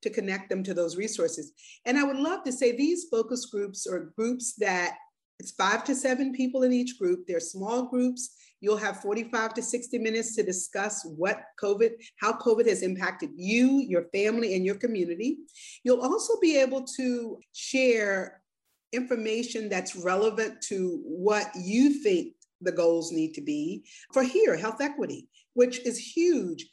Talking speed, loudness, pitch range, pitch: 165 wpm, -28 LUFS, 200-265 Hz, 230 Hz